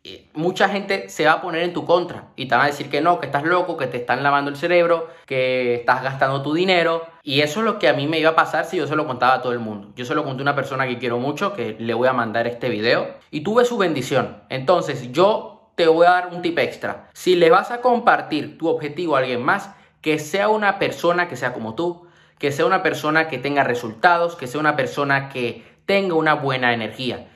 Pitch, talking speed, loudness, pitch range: 150 Hz, 250 wpm, -20 LUFS, 130-175 Hz